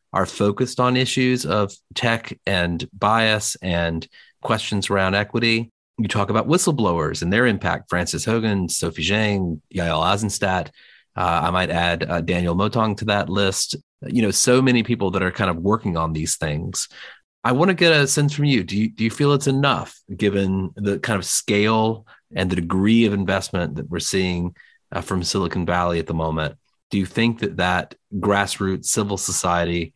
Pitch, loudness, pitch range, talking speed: 100 Hz, -21 LUFS, 90-115 Hz, 180 wpm